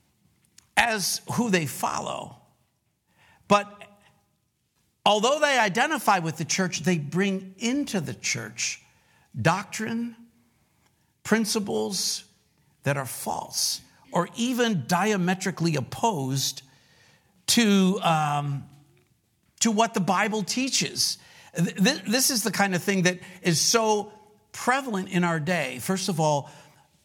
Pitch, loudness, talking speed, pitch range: 195 Hz, -25 LUFS, 105 wpm, 165-220 Hz